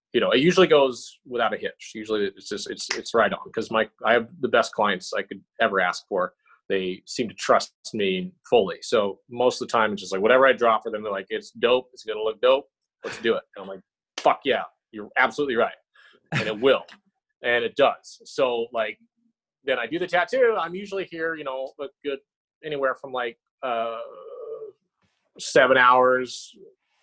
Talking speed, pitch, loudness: 205 wpm, 190 Hz, -23 LUFS